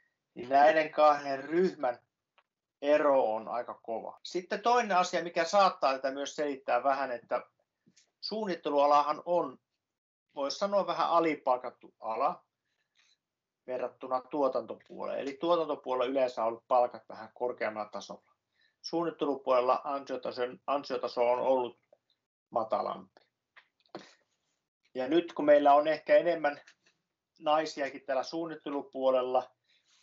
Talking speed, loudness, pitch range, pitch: 105 wpm, -30 LUFS, 130-165 Hz, 140 Hz